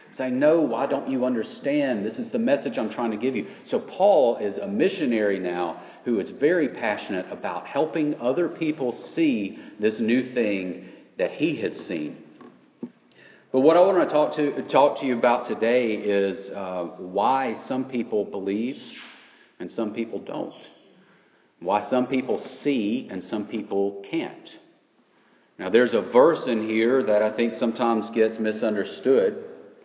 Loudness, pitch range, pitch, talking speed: -24 LUFS, 110-140 Hz, 120 Hz, 160 wpm